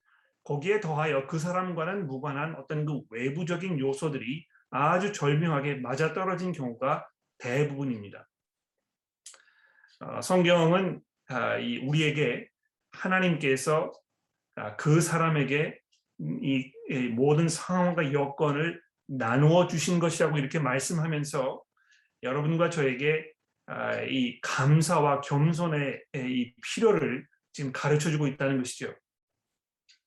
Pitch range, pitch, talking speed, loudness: 140-170 Hz, 150 Hz, 235 characters per minute, -28 LUFS